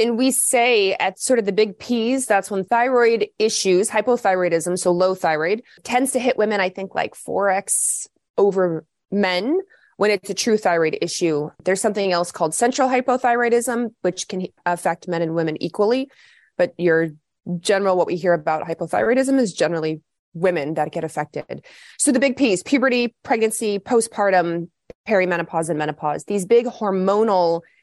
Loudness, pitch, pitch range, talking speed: -20 LUFS, 195 Hz, 175-235 Hz, 155 wpm